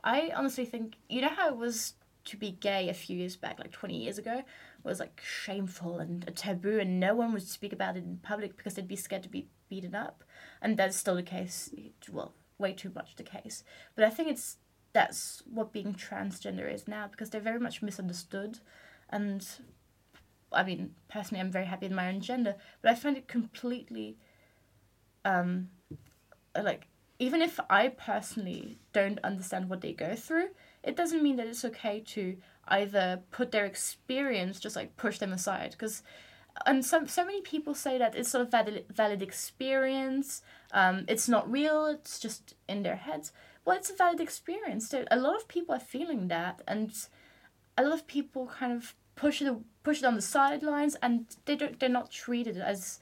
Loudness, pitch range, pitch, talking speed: -33 LUFS, 195-265 Hz, 220 Hz, 190 wpm